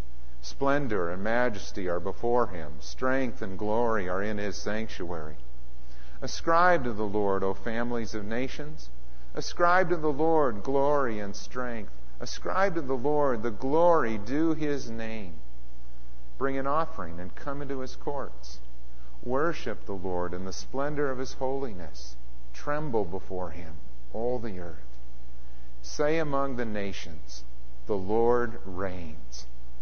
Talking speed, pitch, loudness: 135 wpm, 105 Hz, -30 LUFS